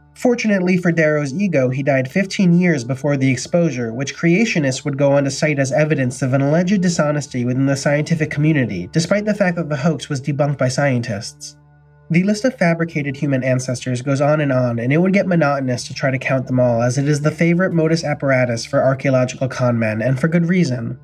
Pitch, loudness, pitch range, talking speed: 145 Hz, -17 LUFS, 130-165 Hz, 210 wpm